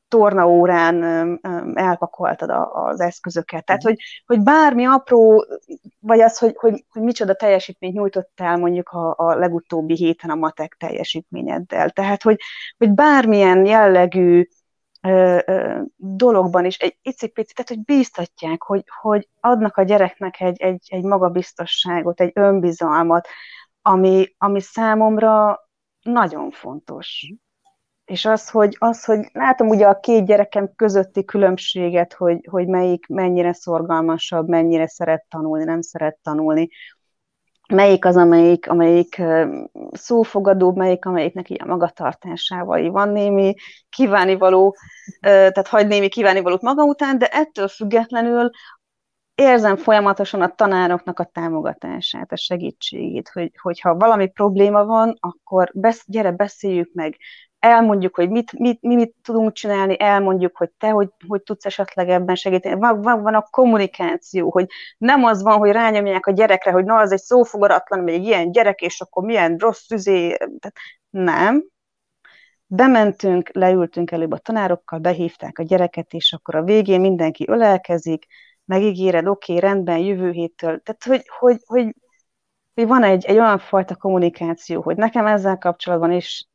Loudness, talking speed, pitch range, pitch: -17 LUFS, 135 wpm, 175-220 Hz, 195 Hz